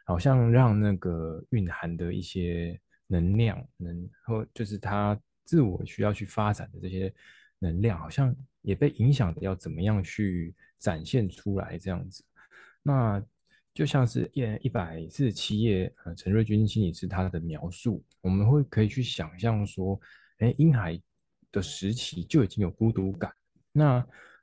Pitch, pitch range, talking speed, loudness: 105 Hz, 90-115 Hz, 230 characters per minute, -28 LUFS